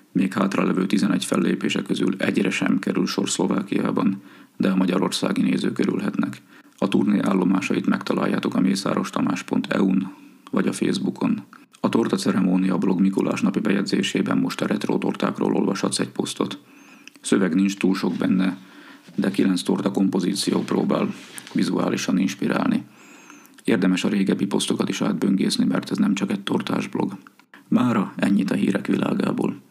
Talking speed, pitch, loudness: 140 wpm, 95 Hz, -22 LUFS